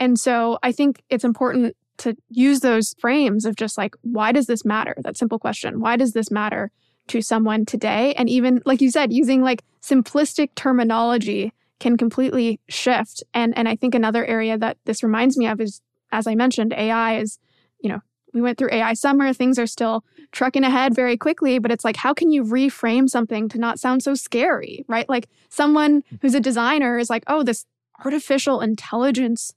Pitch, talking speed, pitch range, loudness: 240 Hz, 195 wpm, 225-260 Hz, -20 LUFS